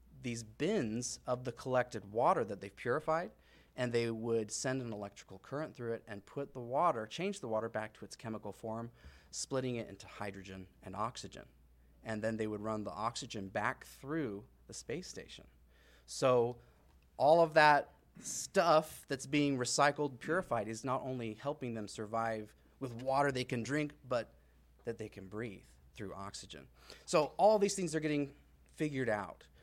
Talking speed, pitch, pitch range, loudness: 170 wpm, 115 Hz, 105-135 Hz, -36 LUFS